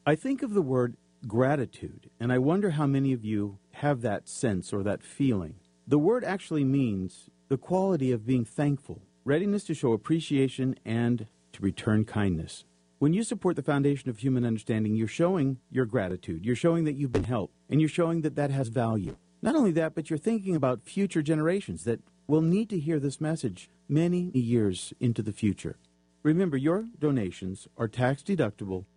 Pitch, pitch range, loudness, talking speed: 130 Hz, 105-160 Hz, -28 LUFS, 180 wpm